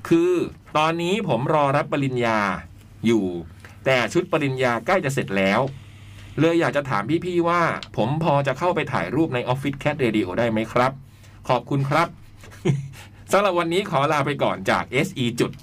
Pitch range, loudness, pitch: 110-160 Hz, -22 LUFS, 135 Hz